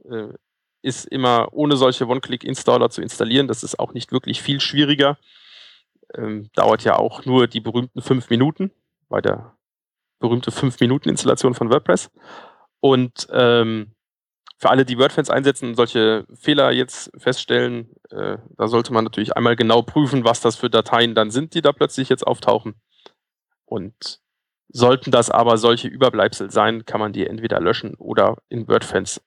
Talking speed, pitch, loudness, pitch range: 155 wpm, 120 Hz, -18 LUFS, 115-135 Hz